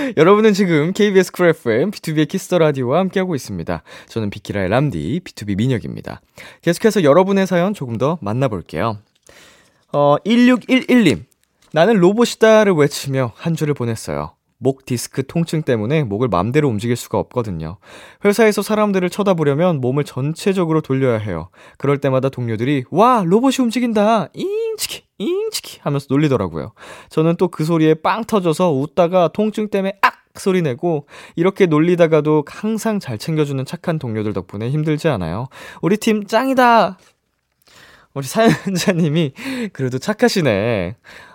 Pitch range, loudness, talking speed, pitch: 130-205 Hz, -17 LUFS, 350 characters per minute, 160 Hz